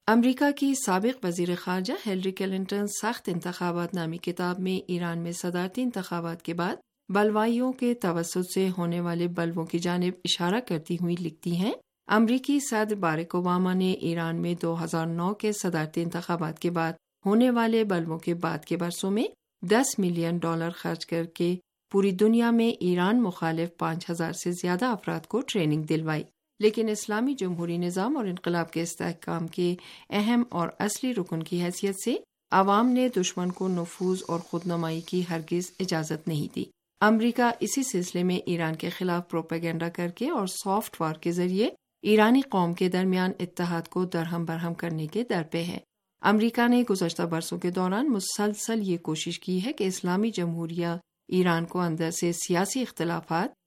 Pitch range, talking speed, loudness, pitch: 170-205 Hz, 170 wpm, -28 LUFS, 180 Hz